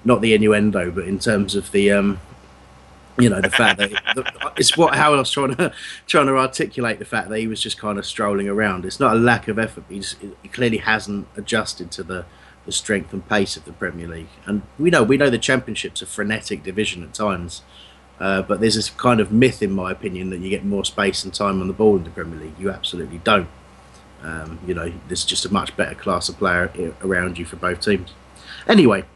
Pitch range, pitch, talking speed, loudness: 85-110 Hz, 100 Hz, 225 wpm, -20 LUFS